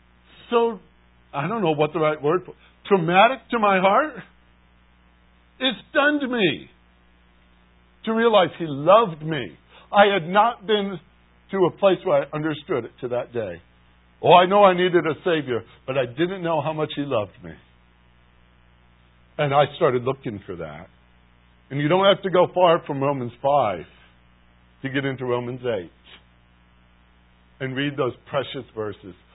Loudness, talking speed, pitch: -21 LUFS, 155 wpm, 130 Hz